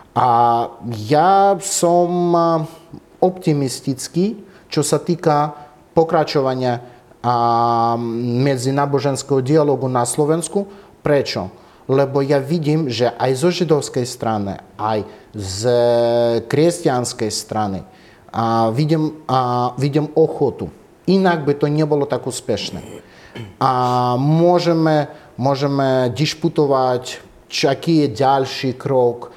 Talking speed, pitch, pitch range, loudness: 90 wpm, 140 Hz, 125-160 Hz, -18 LUFS